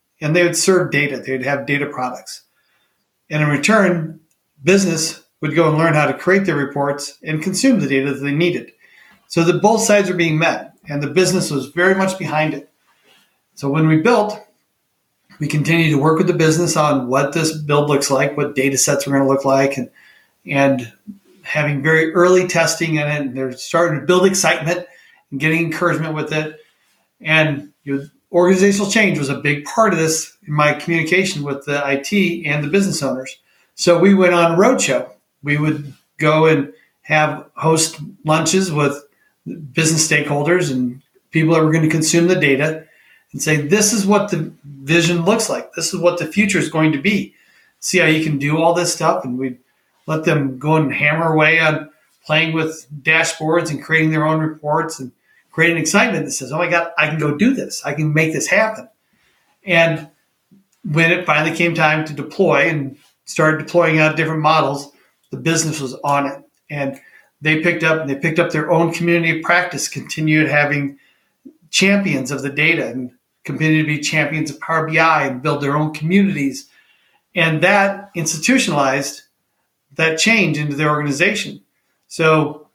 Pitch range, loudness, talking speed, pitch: 145-175 Hz, -16 LUFS, 185 wpm, 160 Hz